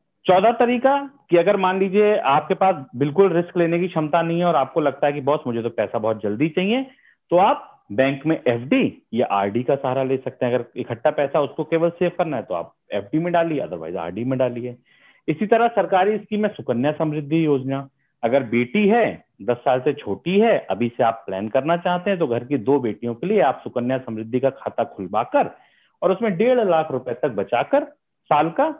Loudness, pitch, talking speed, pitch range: -21 LUFS, 150 Hz, 210 wpm, 125-190 Hz